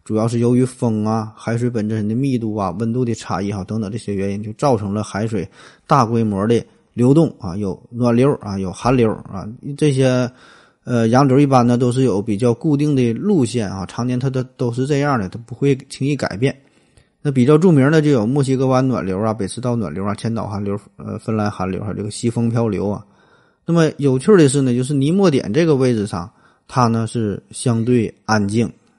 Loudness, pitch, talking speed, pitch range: -18 LUFS, 120 Hz, 305 characters per minute, 105-130 Hz